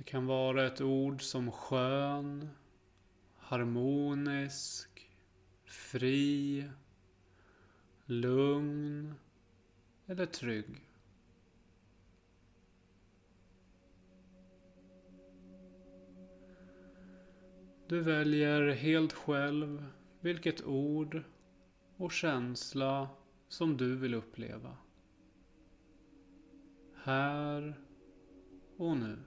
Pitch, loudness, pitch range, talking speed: 120 Hz, -35 LUFS, 95-145 Hz, 55 wpm